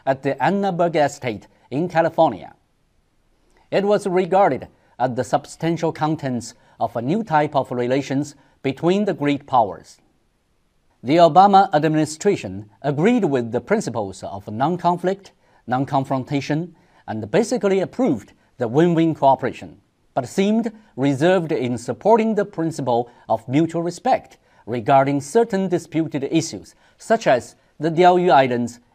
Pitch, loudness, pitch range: 155 Hz, -20 LUFS, 130-180 Hz